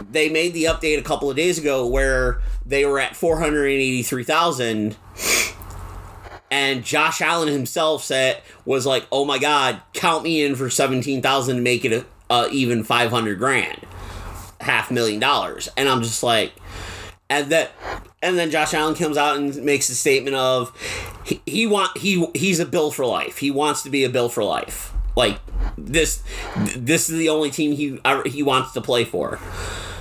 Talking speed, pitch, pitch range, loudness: 190 wpm, 135 Hz, 120-155 Hz, -20 LUFS